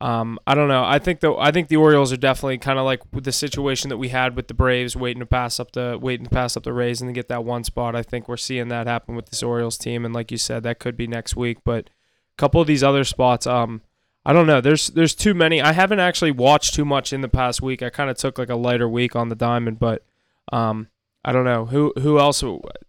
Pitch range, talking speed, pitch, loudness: 120-140 Hz, 275 wpm, 125 Hz, -20 LUFS